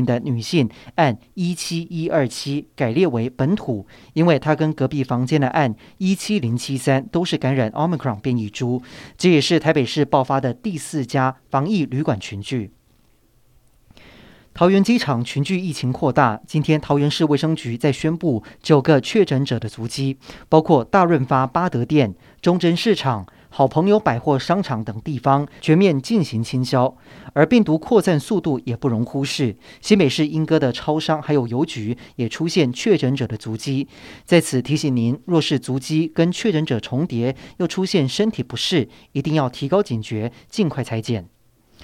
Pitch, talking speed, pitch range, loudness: 140 Hz, 260 characters per minute, 125-160 Hz, -20 LUFS